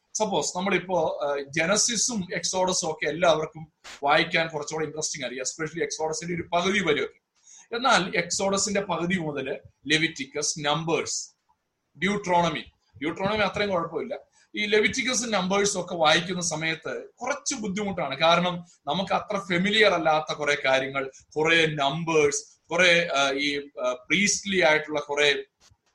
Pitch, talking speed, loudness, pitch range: 170 Hz, 105 wpm, -25 LUFS, 150-200 Hz